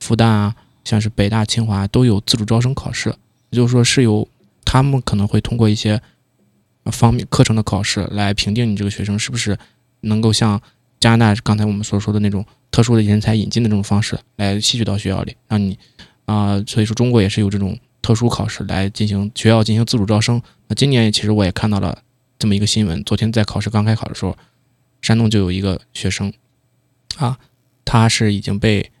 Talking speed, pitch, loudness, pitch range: 320 characters per minute, 110 Hz, -17 LUFS, 105-120 Hz